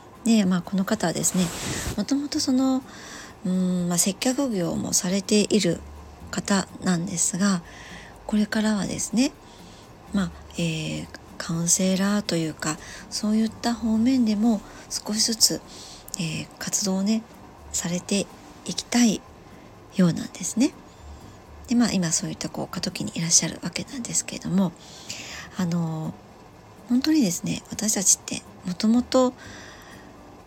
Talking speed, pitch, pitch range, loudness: 260 characters per minute, 200 Hz, 180-225 Hz, -24 LUFS